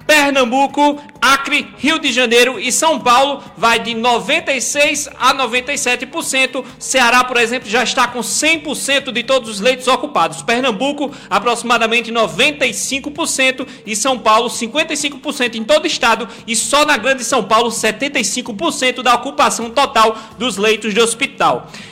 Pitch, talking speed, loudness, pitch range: 255 Hz, 135 wpm, -14 LUFS, 230-275 Hz